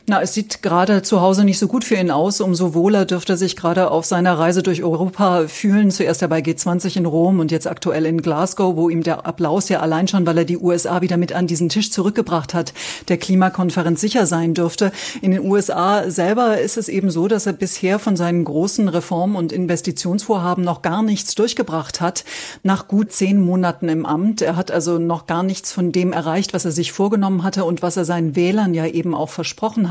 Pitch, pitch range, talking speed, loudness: 180 Hz, 170-195 Hz, 220 wpm, -17 LUFS